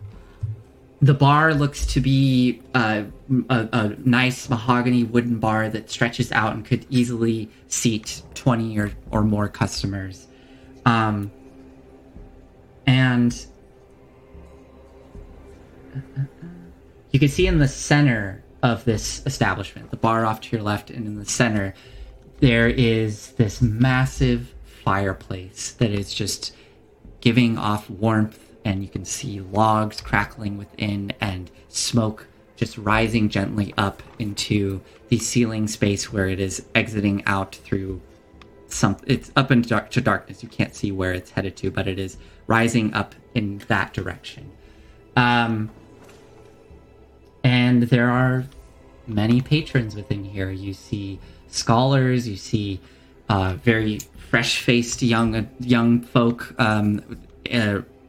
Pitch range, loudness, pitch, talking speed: 100-125 Hz, -22 LUFS, 110 Hz, 125 wpm